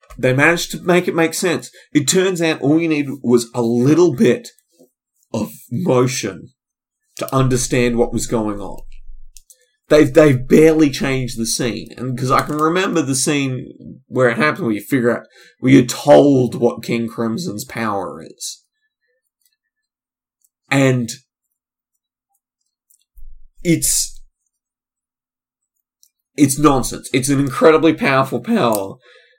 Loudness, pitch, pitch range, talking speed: -16 LUFS, 135 Hz, 120-165 Hz, 125 wpm